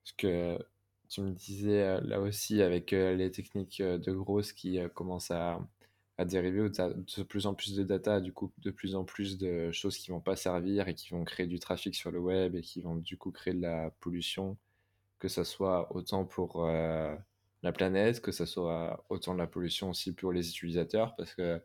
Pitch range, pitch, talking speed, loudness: 85-100 Hz, 95 Hz, 215 wpm, -35 LUFS